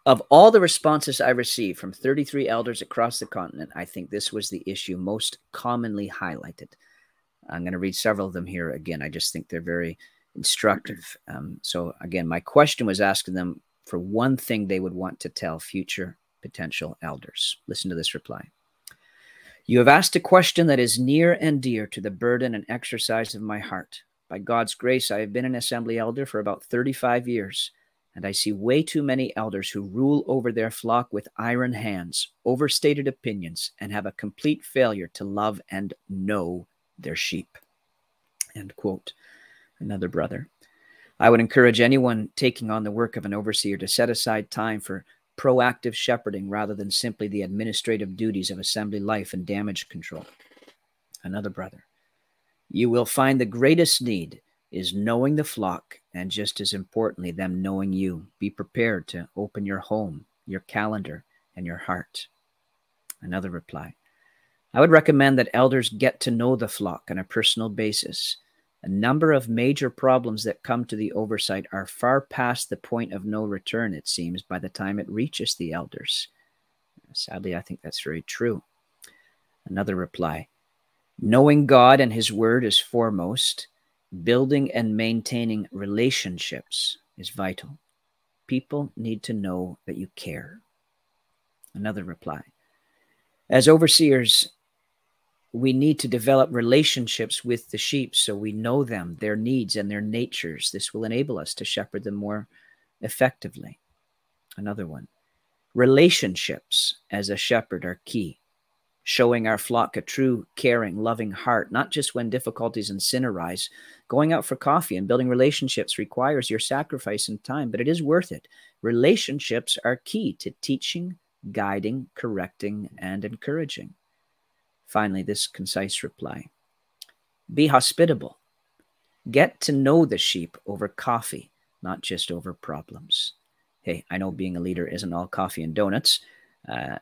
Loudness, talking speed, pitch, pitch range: -23 LUFS, 160 wpm, 110 Hz, 100-125 Hz